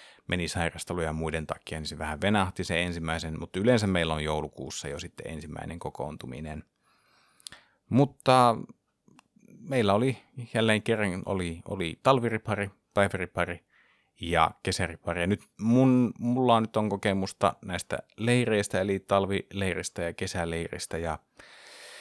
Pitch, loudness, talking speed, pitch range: 95 Hz, -28 LUFS, 120 wpm, 85-110 Hz